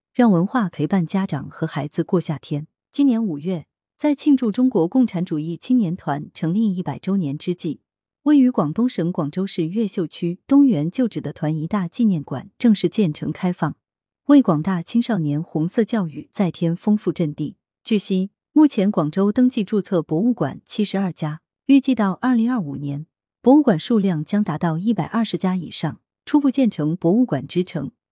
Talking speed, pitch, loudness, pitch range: 275 characters per minute, 185 Hz, -20 LUFS, 160-230 Hz